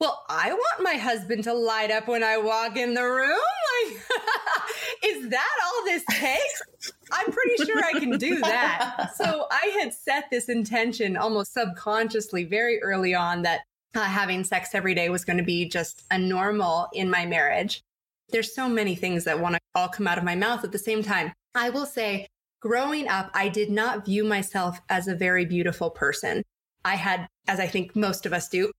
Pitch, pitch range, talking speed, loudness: 215 Hz, 185-245 Hz, 200 wpm, -25 LUFS